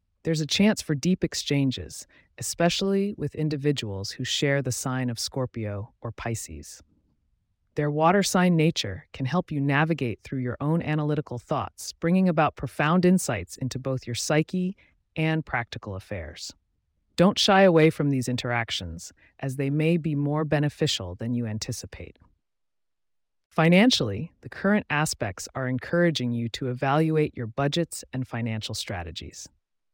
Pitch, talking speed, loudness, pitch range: 130 Hz, 140 wpm, -25 LUFS, 105-155 Hz